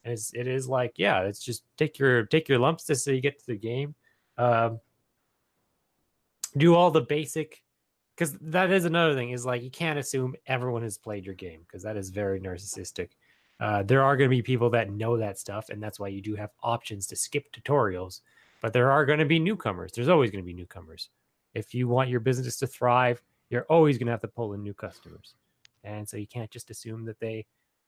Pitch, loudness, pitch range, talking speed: 120 Hz, -27 LUFS, 105-135 Hz, 225 wpm